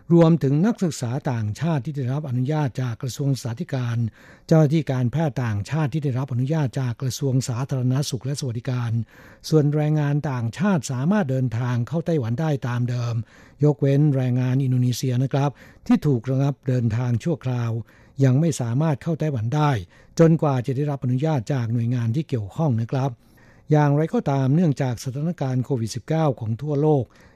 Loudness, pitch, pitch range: -23 LUFS, 135 Hz, 125-150 Hz